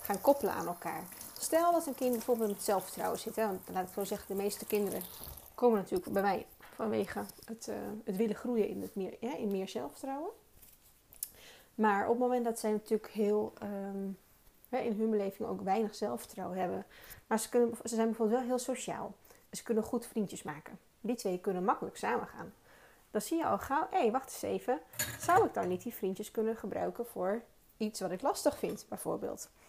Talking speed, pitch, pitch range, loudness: 205 wpm, 220 Hz, 200-240 Hz, -35 LUFS